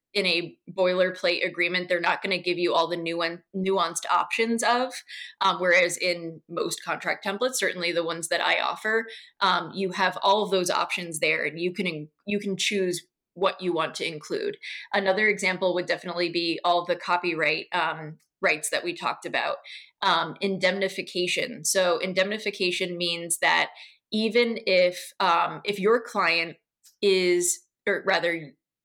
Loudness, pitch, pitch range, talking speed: -25 LUFS, 185 Hz, 175-200 Hz, 155 wpm